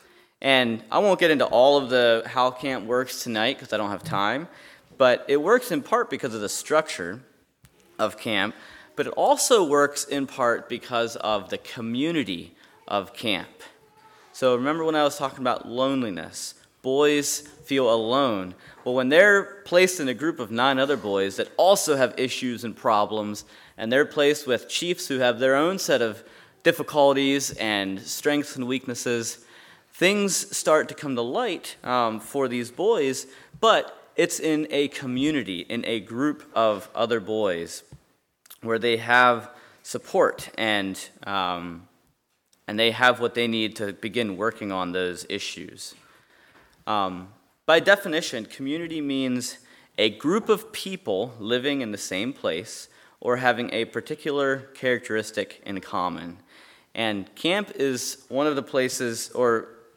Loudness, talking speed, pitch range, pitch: -24 LUFS, 150 wpm, 115-145 Hz, 125 Hz